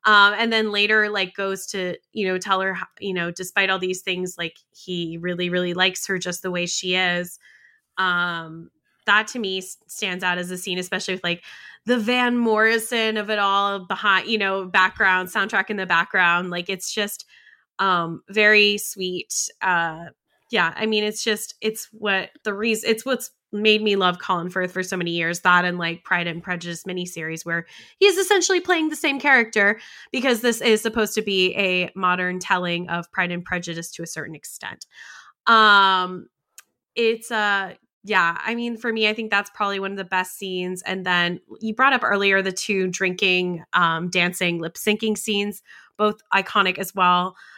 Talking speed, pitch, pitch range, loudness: 185 wpm, 190 Hz, 180-215 Hz, -21 LUFS